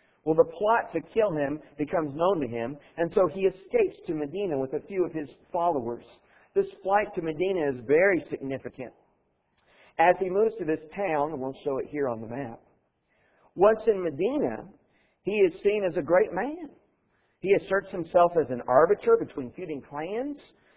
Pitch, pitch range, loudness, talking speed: 180 Hz, 150-215 Hz, -27 LUFS, 175 wpm